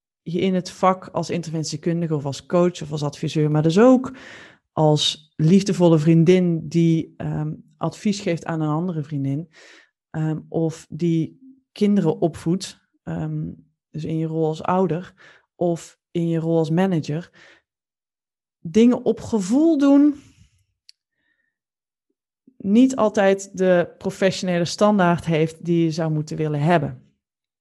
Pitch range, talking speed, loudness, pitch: 155-190 Hz, 130 wpm, -21 LUFS, 165 Hz